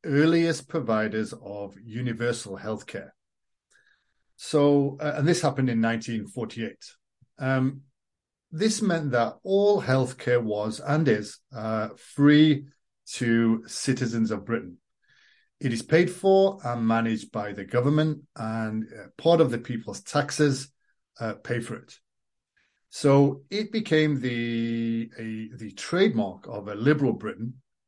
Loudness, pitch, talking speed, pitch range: -25 LUFS, 125 Hz, 125 wpm, 115-150 Hz